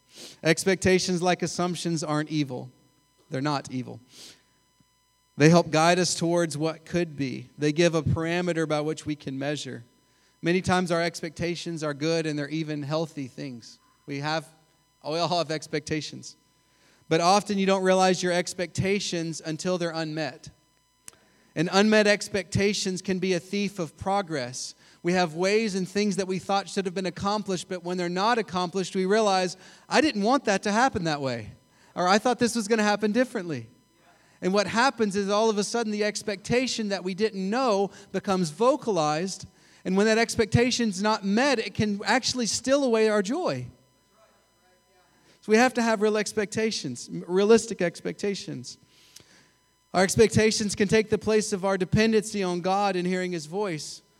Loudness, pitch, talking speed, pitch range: -25 LUFS, 185 Hz, 165 wpm, 160-205 Hz